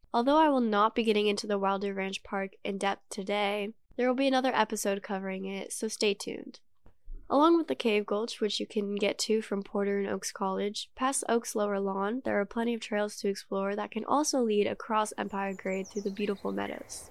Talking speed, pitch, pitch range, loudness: 215 wpm, 205 Hz, 200-225 Hz, -30 LUFS